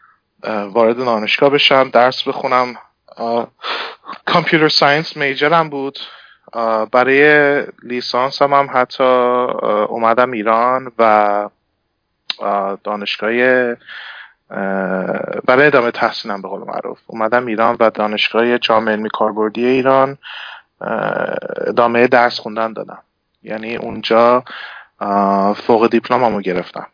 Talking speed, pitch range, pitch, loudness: 95 wpm, 110-130 Hz, 120 Hz, -15 LUFS